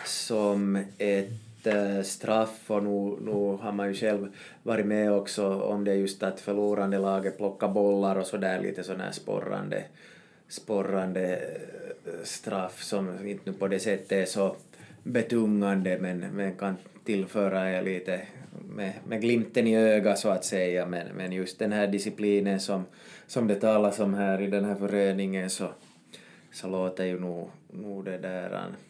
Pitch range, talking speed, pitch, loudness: 95-105 Hz, 165 wpm, 100 Hz, -29 LUFS